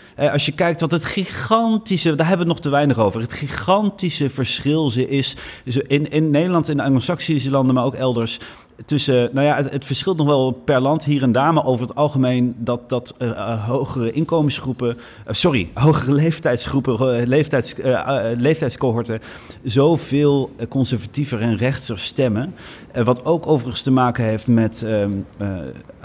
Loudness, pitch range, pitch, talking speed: -19 LUFS, 120-150 Hz, 135 Hz, 175 wpm